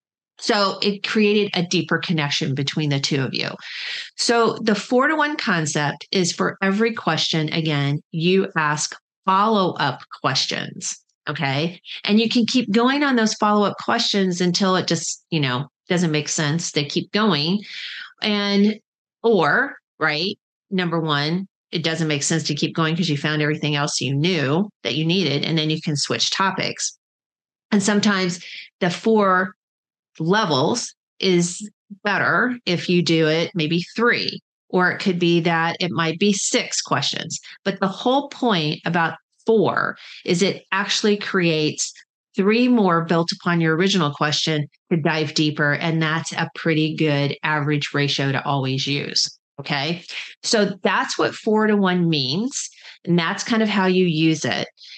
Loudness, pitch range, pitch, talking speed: -20 LUFS, 155-200 Hz, 175 Hz, 160 wpm